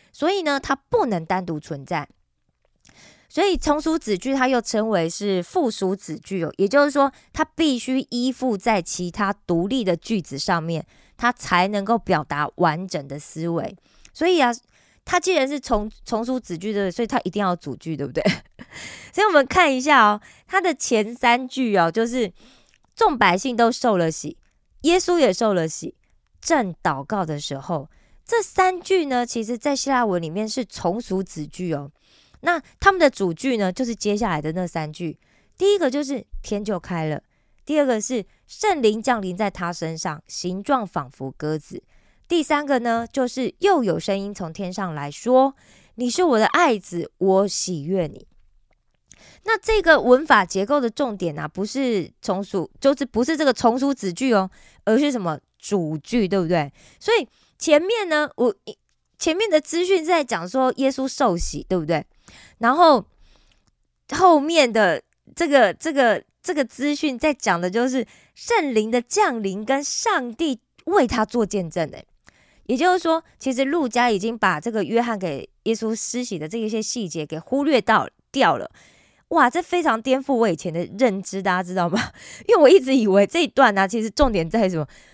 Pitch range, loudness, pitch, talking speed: 185-280 Hz, -21 LUFS, 230 Hz, 250 characters per minute